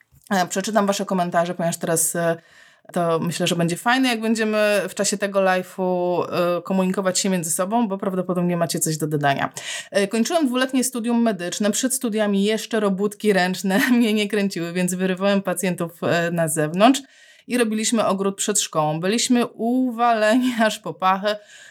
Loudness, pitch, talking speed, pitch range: -21 LUFS, 200 Hz, 145 wpm, 175-225 Hz